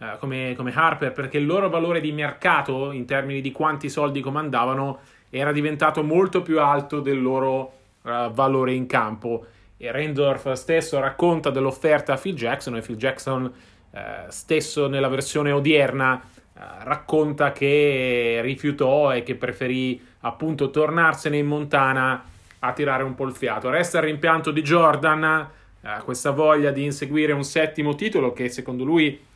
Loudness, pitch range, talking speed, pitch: -22 LUFS, 130-155 Hz, 155 wpm, 140 Hz